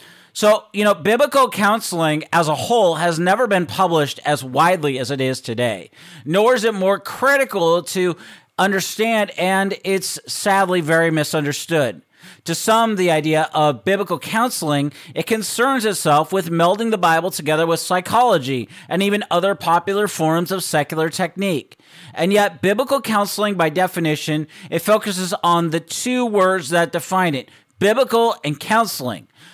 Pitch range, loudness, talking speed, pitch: 160-205 Hz, -18 LUFS, 150 wpm, 180 Hz